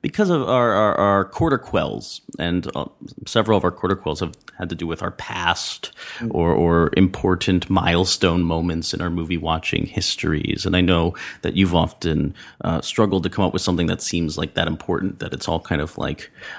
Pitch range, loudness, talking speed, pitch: 85-95 Hz, -21 LUFS, 205 wpm, 90 Hz